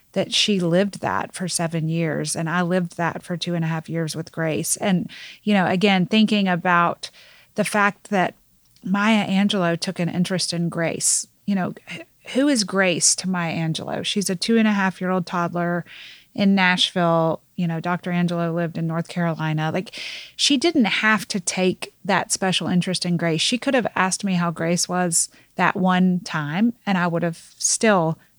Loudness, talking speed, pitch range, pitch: -21 LUFS, 190 wpm, 170-200 Hz, 180 Hz